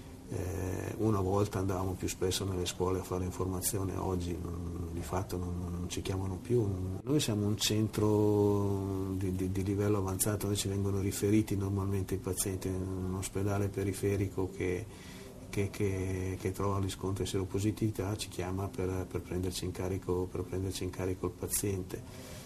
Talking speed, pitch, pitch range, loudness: 160 wpm, 95 Hz, 90-100 Hz, -34 LUFS